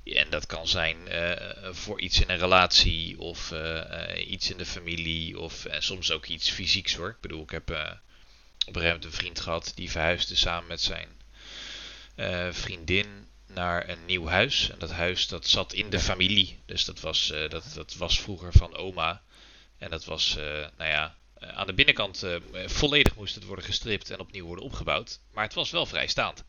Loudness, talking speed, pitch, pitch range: -27 LUFS, 200 wpm, 90 Hz, 80-95 Hz